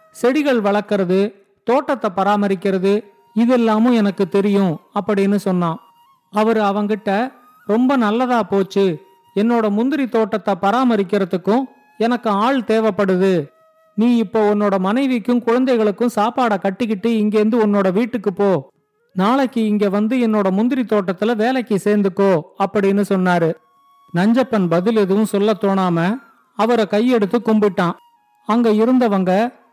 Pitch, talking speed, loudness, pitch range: 210 Hz, 105 wpm, -17 LUFS, 195-235 Hz